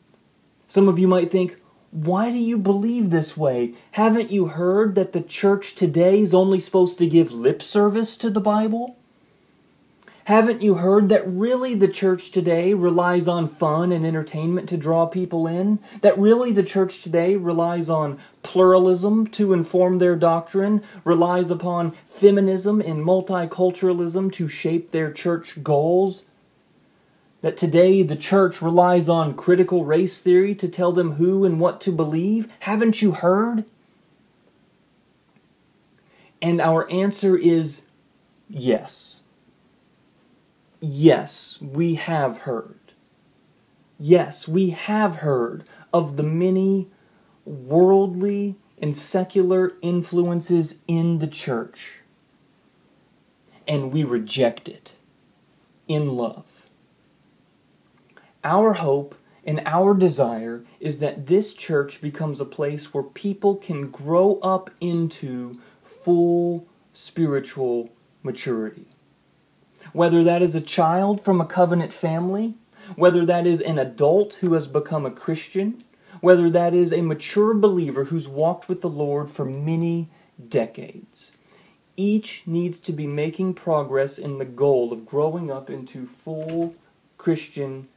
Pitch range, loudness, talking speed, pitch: 160-190 Hz, -21 LUFS, 125 wpm, 175 Hz